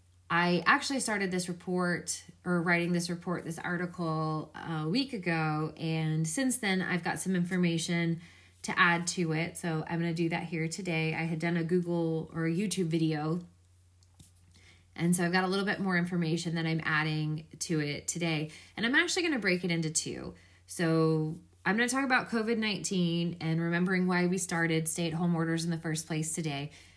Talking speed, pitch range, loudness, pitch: 195 wpm, 160-180 Hz, -31 LUFS, 170 Hz